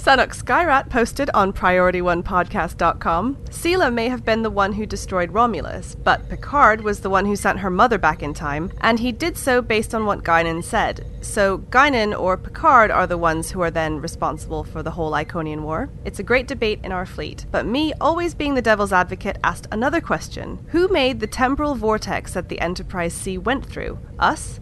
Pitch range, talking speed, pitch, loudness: 180-250 Hz, 195 wpm, 210 Hz, -20 LUFS